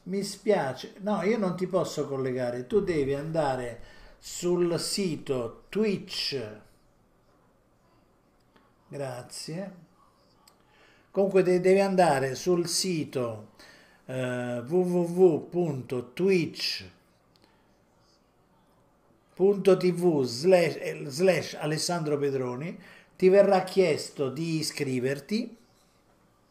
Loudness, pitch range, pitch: -27 LUFS, 140-190 Hz, 175 Hz